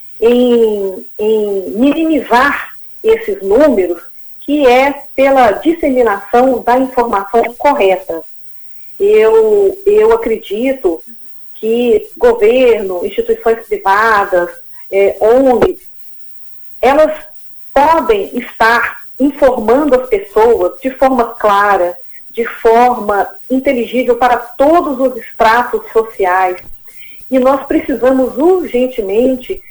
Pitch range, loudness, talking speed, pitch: 230-325 Hz, -11 LUFS, 85 wpm, 255 Hz